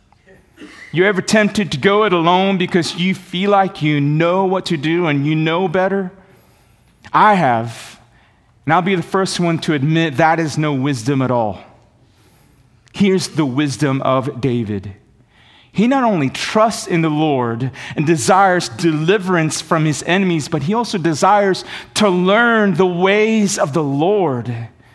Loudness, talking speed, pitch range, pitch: -16 LUFS, 155 wpm, 140-190 Hz, 165 Hz